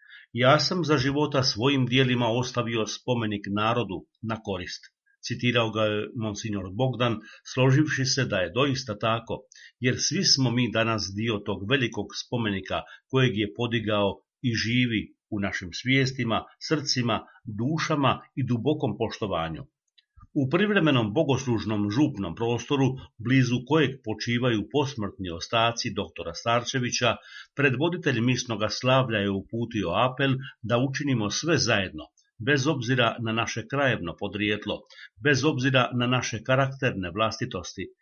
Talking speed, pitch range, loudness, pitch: 125 wpm, 110-135 Hz, -26 LUFS, 120 Hz